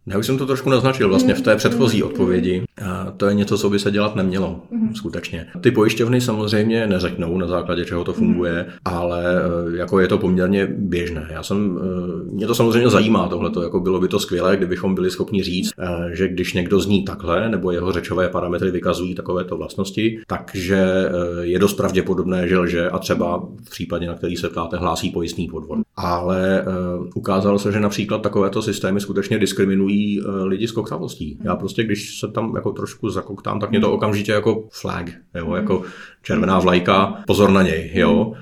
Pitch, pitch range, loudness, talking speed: 95 Hz, 90-105 Hz, -20 LUFS, 175 wpm